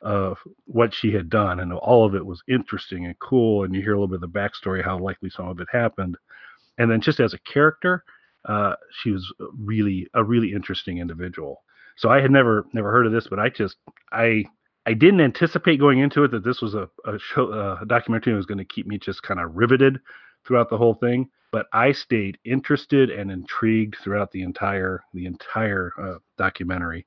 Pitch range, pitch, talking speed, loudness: 95-120 Hz, 110 Hz, 210 wpm, -22 LUFS